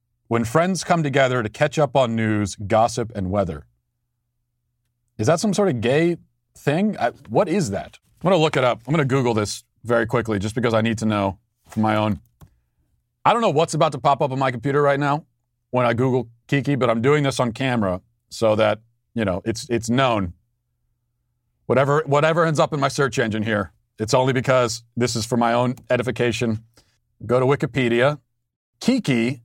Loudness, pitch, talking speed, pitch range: -21 LUFS, 120 Hz, 200 wpm, 115-140 Hz